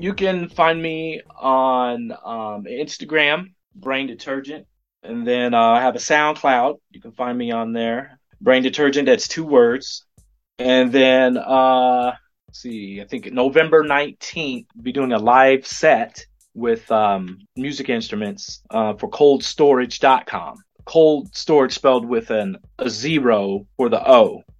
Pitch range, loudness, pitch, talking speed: 115-150 Hz, -18 LUFS, 130 Hz, 145 wpm